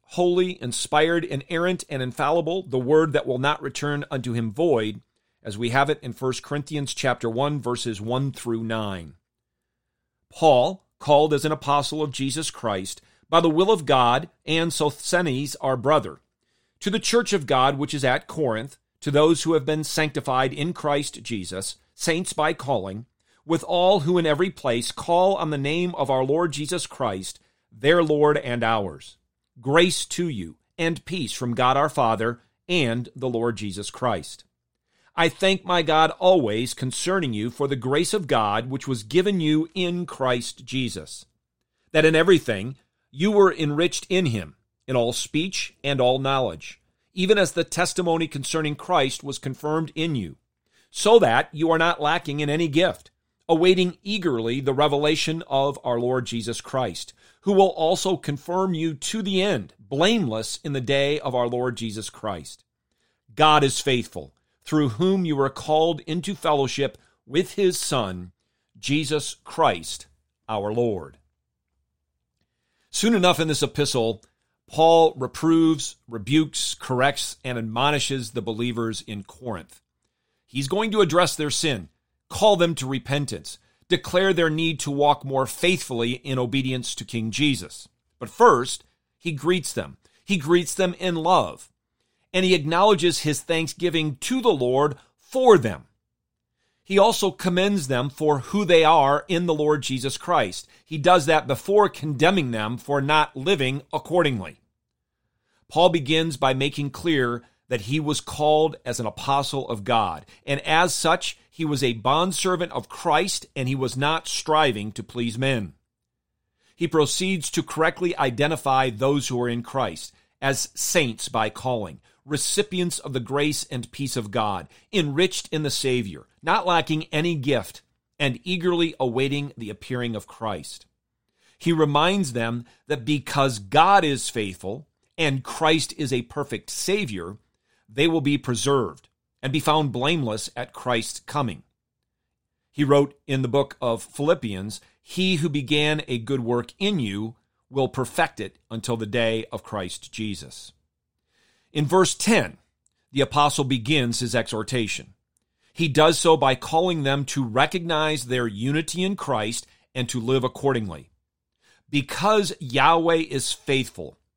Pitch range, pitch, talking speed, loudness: 120-165 Hz, 140 Hz, 155 wpm, -23 LUFS